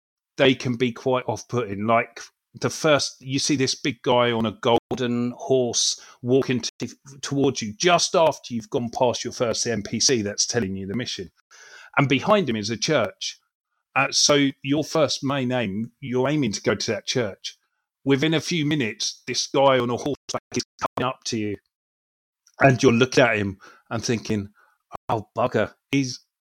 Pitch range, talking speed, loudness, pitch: 115-140 Hz, 175 wpm, -23 LUFS, 125 Hz